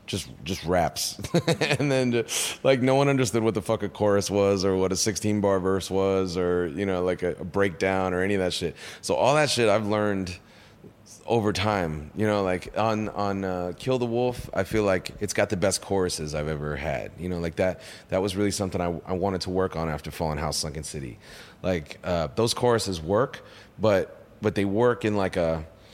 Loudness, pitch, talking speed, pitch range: -26 LUFS, 95 Hz, 215 wpm, 90-110 Hz